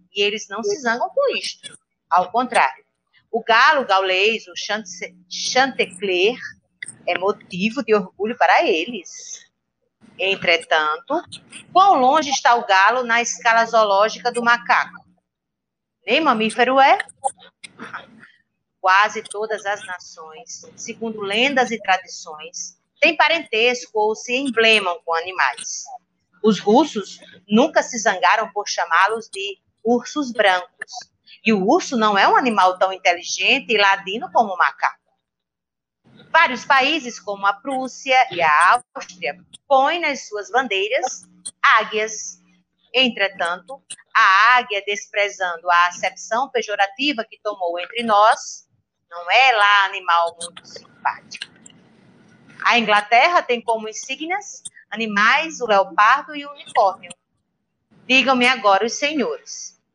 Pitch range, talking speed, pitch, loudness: 195-260 Hz, 120 wpm, 220 Hz, -18 LUFS